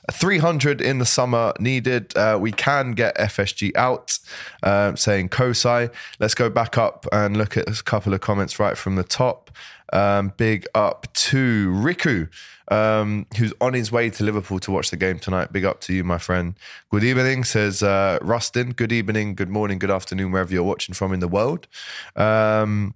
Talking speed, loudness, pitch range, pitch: 185 wpm, -21 LUFS, 100-120 Hz, 105 Hz